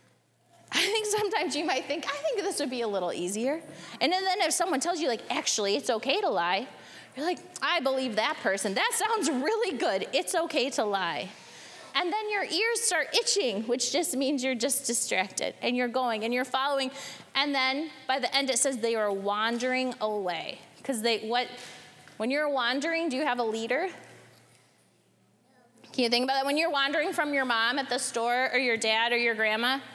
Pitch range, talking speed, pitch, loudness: 235-320 Hz, 205 wpm, 265 Hz, -28 LUFS